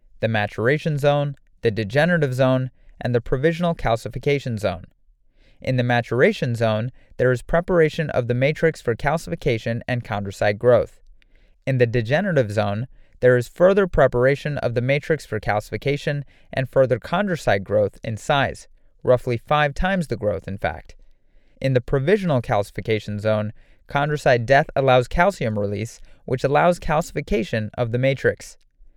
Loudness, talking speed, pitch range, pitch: -21 LUFS, 140 wpm, 115-145 Hz, 125 Hz